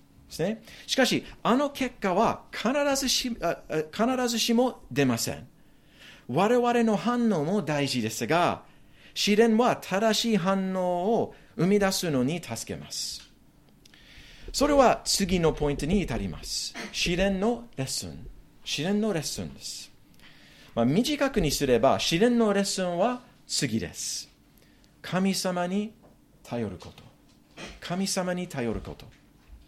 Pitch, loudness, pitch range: 190 Hz, -26 LUFS, 140-230 Hz